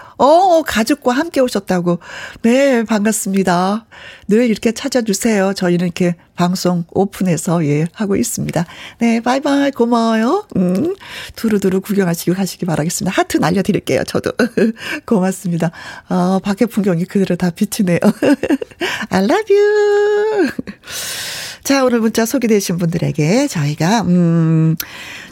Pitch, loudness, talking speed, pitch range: 210 Hz, -15 LUFS, 310 characters per minute, 180-250 Hz